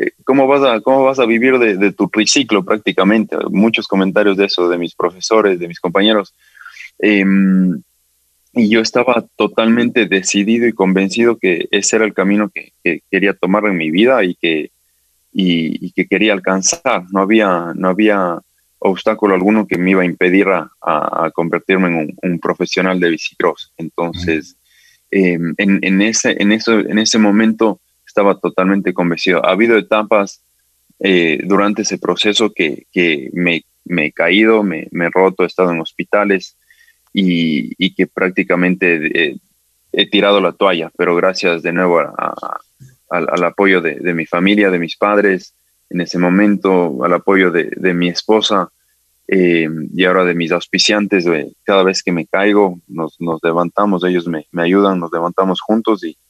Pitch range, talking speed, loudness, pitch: 90-105 Hz, 170 wpm, -14 LUFS, 95 Hz